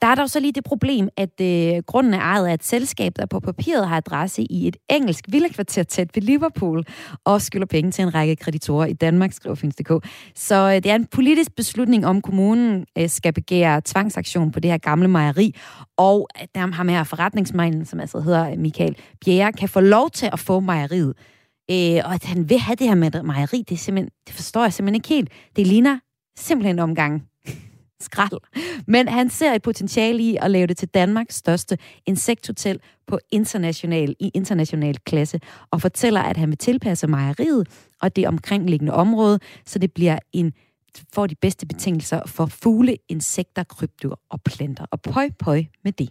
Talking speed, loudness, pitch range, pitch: 185 wpm, -20 LUFS, 160-210 Hz, 185 Hz